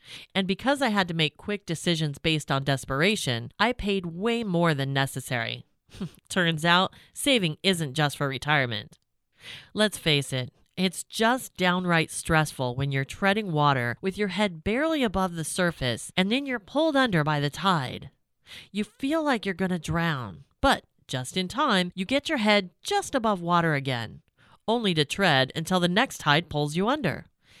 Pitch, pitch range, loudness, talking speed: 175 Hz, 145-205 Hz, -26 LUFS, 170 wpm